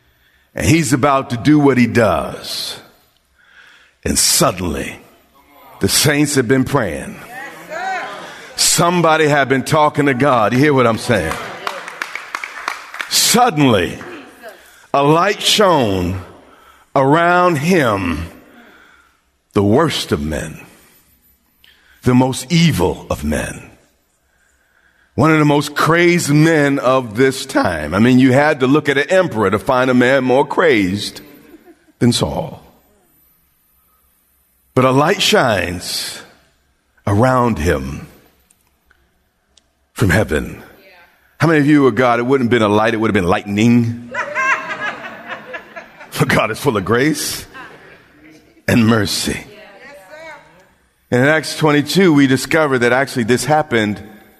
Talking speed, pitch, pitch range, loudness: 120 wpm, 130 Hz, 110-150 Hz, -14 LUFS